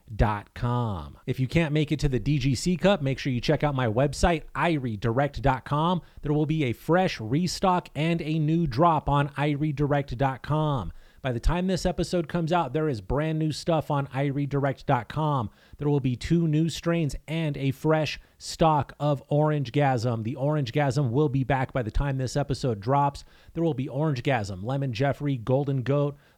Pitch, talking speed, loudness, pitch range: 145 Hz, 180 wpm, -26 LUFS, 130-155 Hz